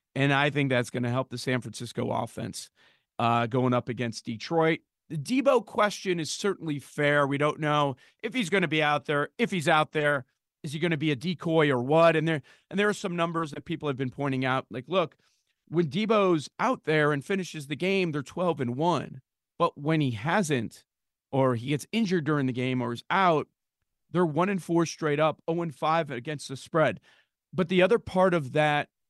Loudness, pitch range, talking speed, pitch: -27 LUFS, 130-175 Hz, 215 wpm, 150 Hz